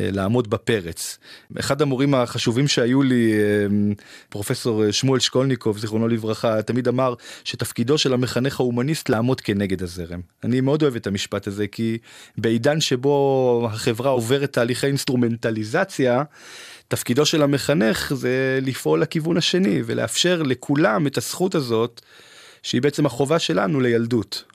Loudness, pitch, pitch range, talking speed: -21 LUFS, 125 Hz, 115-140 Hz, 125 wpm